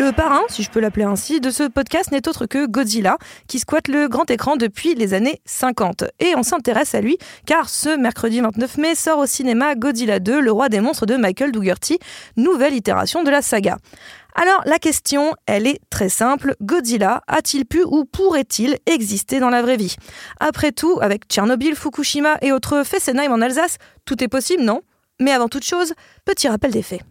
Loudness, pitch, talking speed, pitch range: -18 LUFS, 275 Hz, 195 wpm, 235-305 Hz